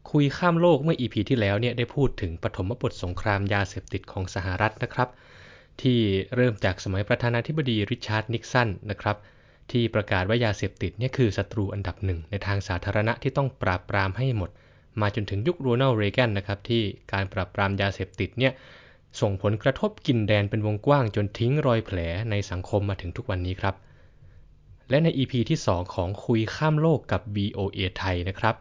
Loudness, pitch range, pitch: -26 LUFS, 100-125 Hz, 105 Hz